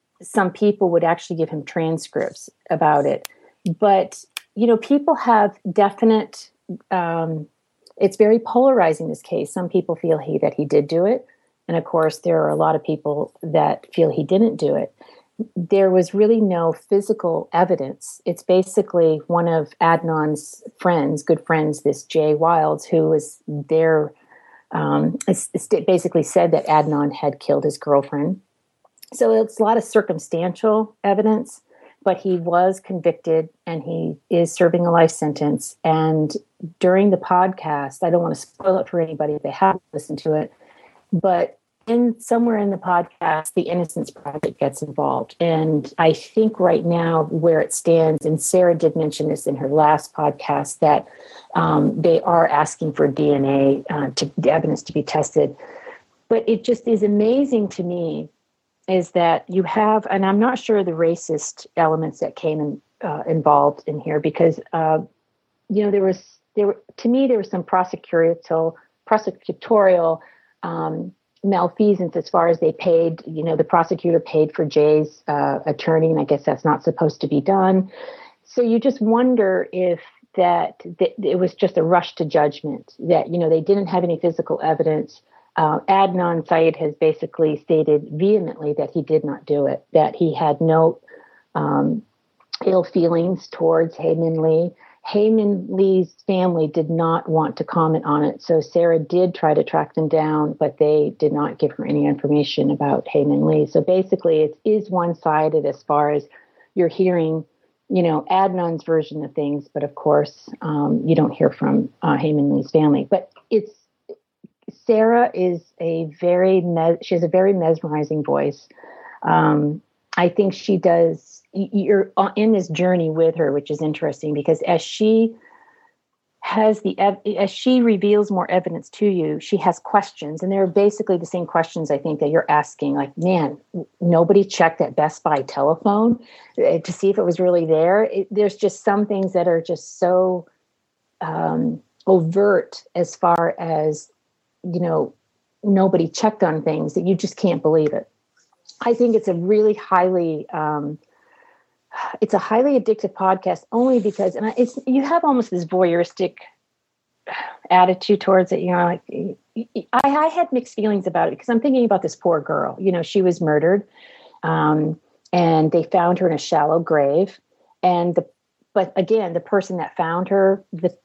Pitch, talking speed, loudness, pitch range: 175 Hz, 170 wpm, -19 LUFS, 160-200 Hz